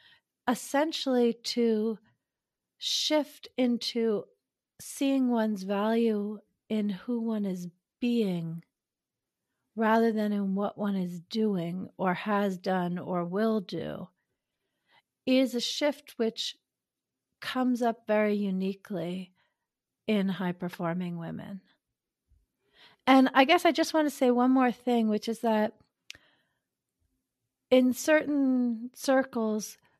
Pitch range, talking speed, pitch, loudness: 195-250 Hz, 110 wpm, 220 Hz, -28 LUFS